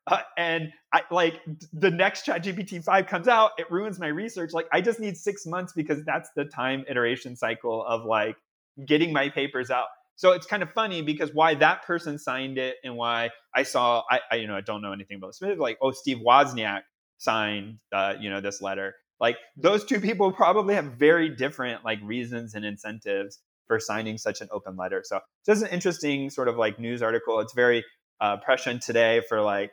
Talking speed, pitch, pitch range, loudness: 205 wpm, 140 Hz, 115-175 Hz, -26 LUFS